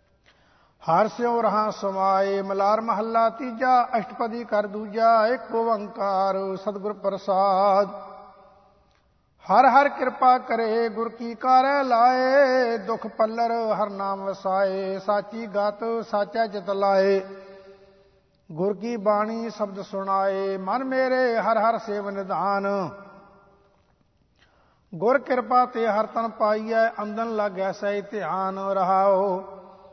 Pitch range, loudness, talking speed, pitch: 195-230 Hz, -23 LUFS, 110 wpm, 210 Hz